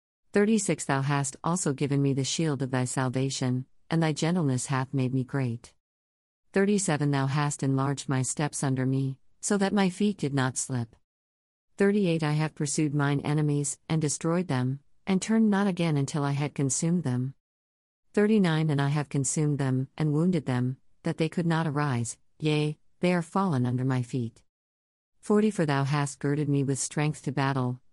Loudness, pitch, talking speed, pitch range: -27 LUFS, 140 Hz, 175 wpm, 130-160 Hz